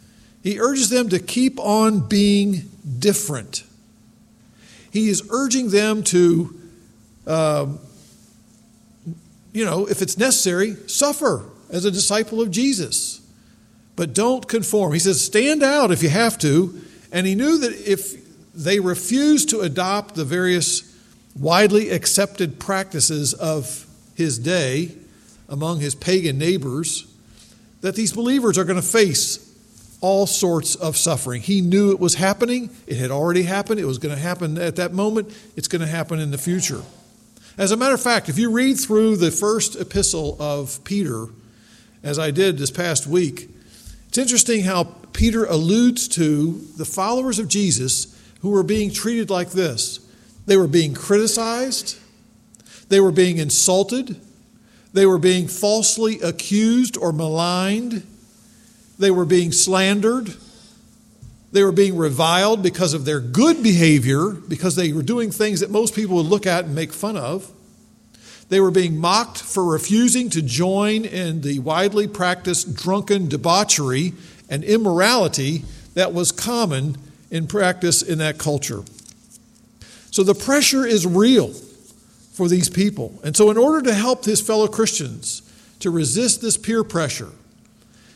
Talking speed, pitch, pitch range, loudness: 150 wpm, 190 Hz, 165-215 Hz, -19 LUFS